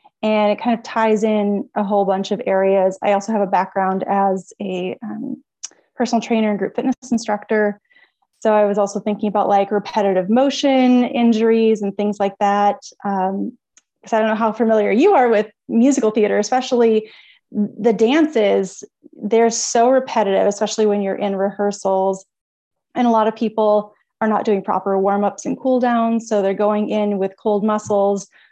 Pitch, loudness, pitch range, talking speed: 210 Hz, -18 LUFS, 200-230 Hz, 170 wpm